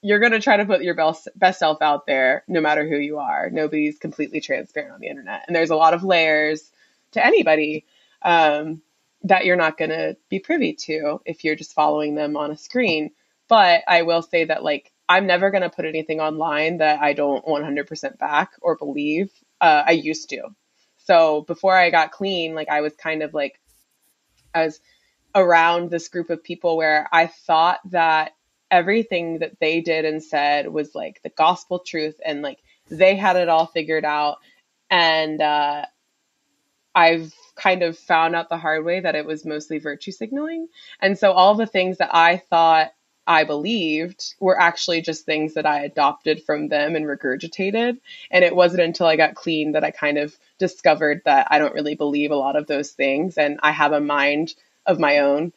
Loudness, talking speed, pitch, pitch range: -19 LUFS, 195 wpm, 160 Hz, 150-175 Hz